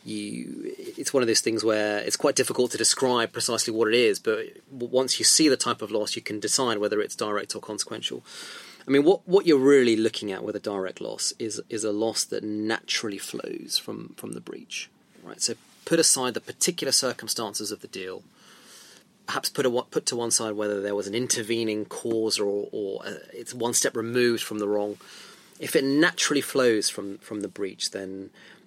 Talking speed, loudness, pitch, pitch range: 205 wpm, -25 LUFS, 115 Hz, 105-130 Hz